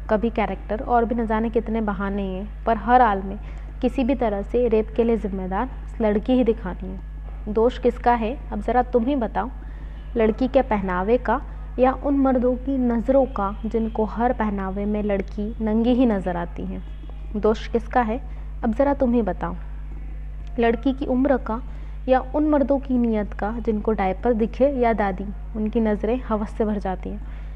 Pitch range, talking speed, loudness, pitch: 205-245 Hz, 180 wpm, -23 LUFS, 225 Hz